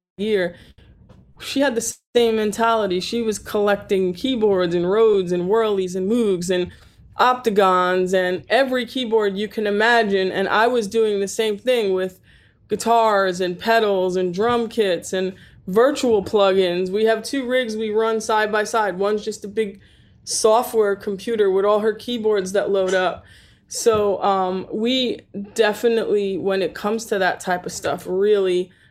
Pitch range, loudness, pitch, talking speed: 190-225 Hz, -20 LUFS, 210 Hz, 160 wpm